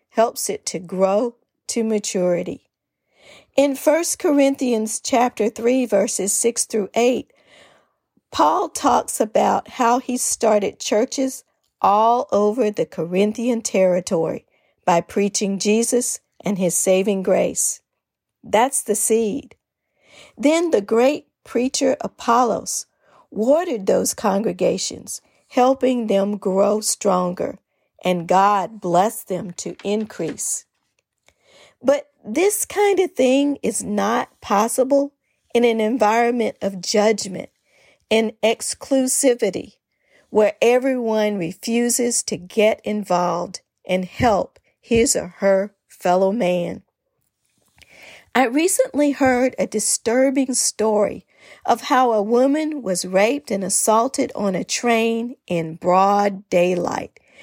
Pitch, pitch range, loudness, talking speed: 220 Hz, 195-255 Hz, -19 LUFS, 110 wpm